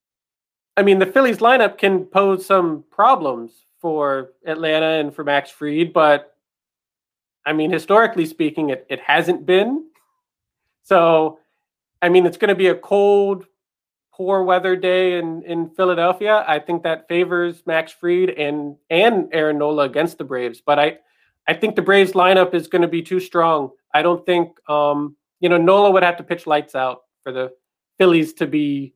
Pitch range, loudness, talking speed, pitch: 150-185 Hz, -17 LUFS, 170 wpm, 170 Hz